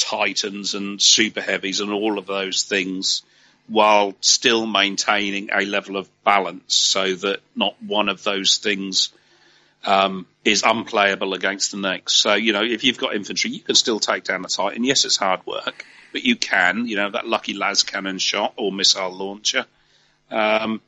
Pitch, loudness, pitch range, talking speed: 100 Hz, -19 LUFS, 95-105 Hz, 175 wpm